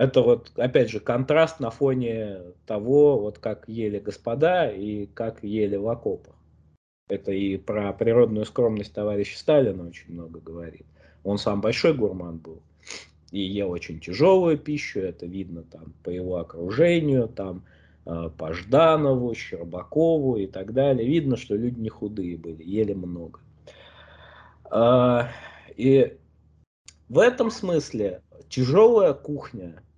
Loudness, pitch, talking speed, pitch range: -23 LUFS, 105 Hz, 130 wpm, 90-130 Hz